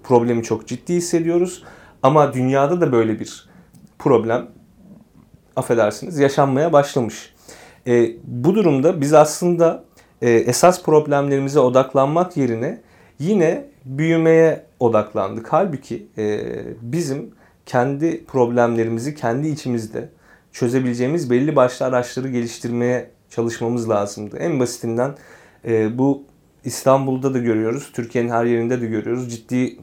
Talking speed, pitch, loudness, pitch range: 105 wpm, 125 Hz, -19 LUFS, 115-145 Hz